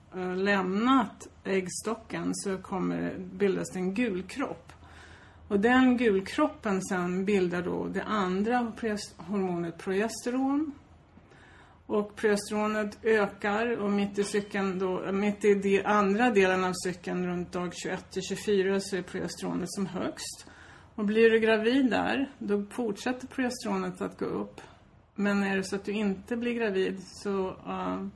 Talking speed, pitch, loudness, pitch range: 145 wpm, 200 Hz, -29 LUFS, 190-220 Hz